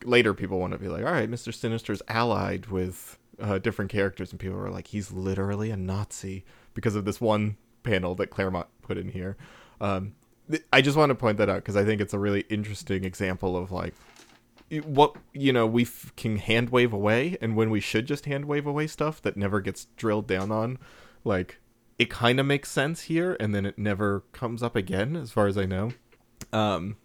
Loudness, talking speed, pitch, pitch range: -27 LUFS, 215 wpm, 110 Hz, 100-120 Hz